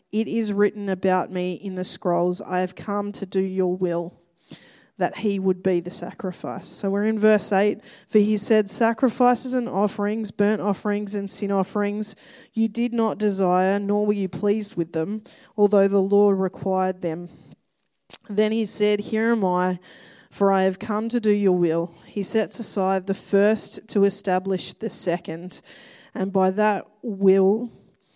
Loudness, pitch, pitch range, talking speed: -23 LUFS, 200 Hz, 185-215 Hz, 170 wpm